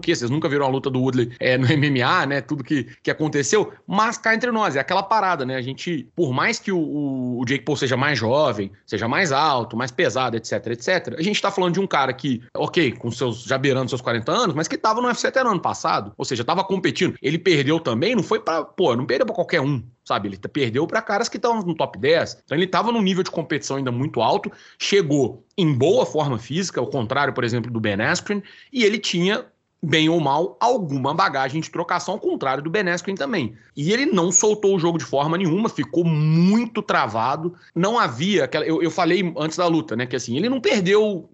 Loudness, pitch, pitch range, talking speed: -21 LUFS, 160 Hz, 135-195 Hz, 230 wpm